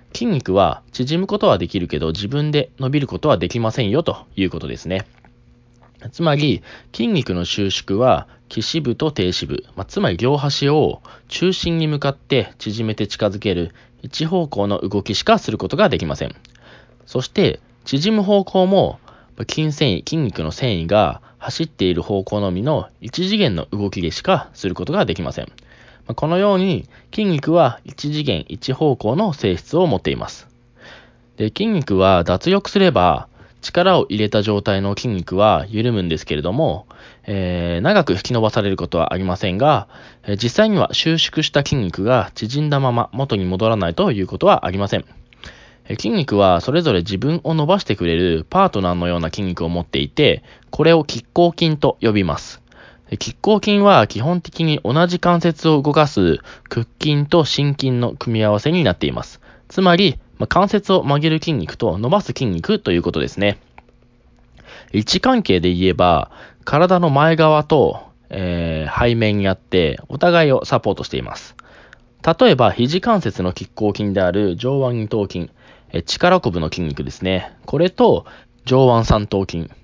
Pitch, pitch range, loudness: 120 Hz, 95-155 Hz, -18 LUFS